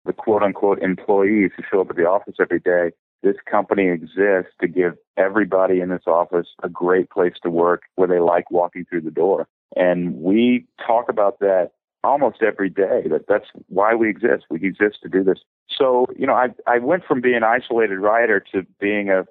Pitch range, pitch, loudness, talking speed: 90-105 Hz, 95 Hz, -19 LUFS, 200 wpm